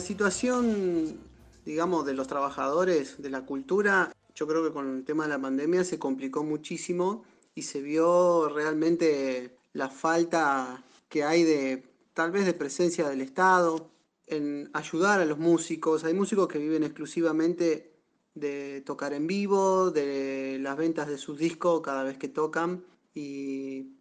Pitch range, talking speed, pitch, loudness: 140-170 Hz, 150 wpm, 155 Hz, -28 LUFS